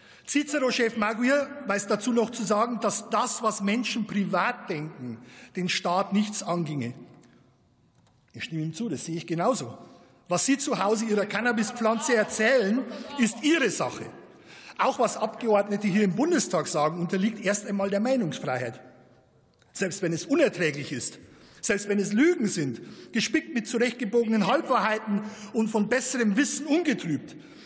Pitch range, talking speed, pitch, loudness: 180-240 Hz, 145 wpm, 215 Hz, -26 LUFS